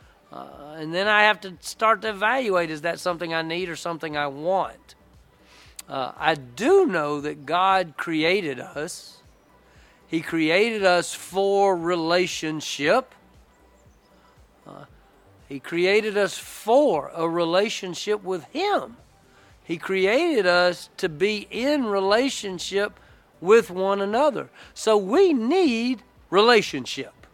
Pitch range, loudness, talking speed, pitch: 165-215 Hz, -23 LUFS, 120 wpm, 190 Hz